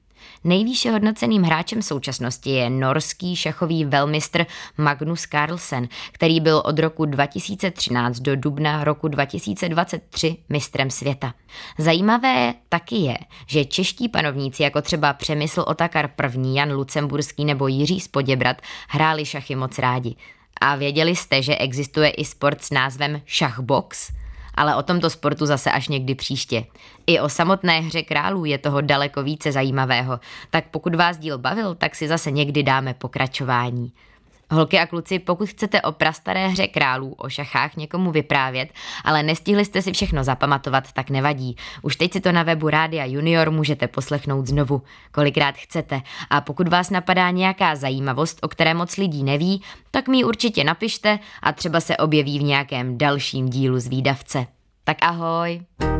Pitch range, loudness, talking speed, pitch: 135-170 Hz, -21 LUFS, 150 wpm, 150 Hz